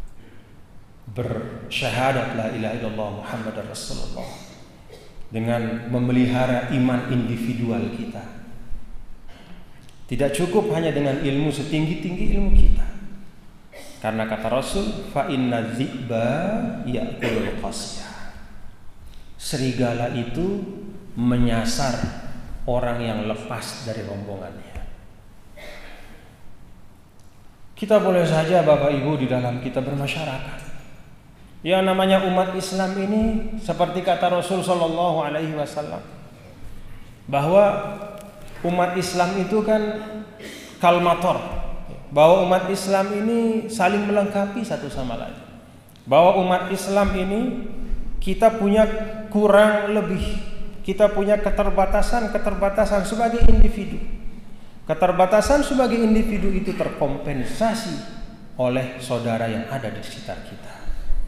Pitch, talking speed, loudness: 155 Hz, 90 wpm, -22 LUFS